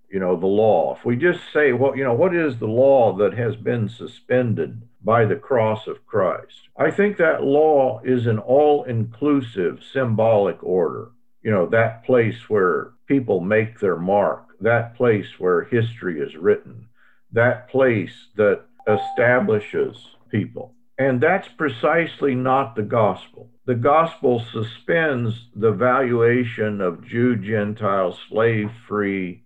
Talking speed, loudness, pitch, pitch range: 145 wpm, -20 LUFS, 120 Hz, 110-140 Hz